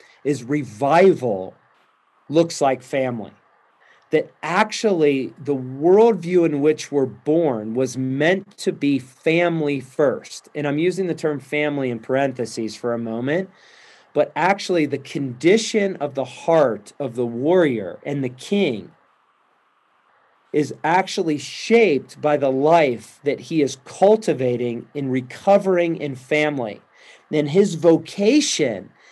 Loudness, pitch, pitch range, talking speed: -20 LUFS, 150 Hz, 130-175 Hz, 125 wpm